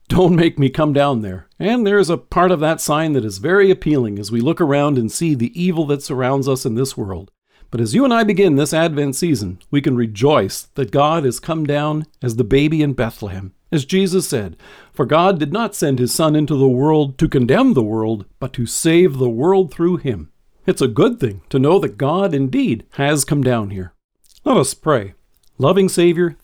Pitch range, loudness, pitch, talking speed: 125-165 Hz, -16 LUFS, 145 Hz, 220 wpm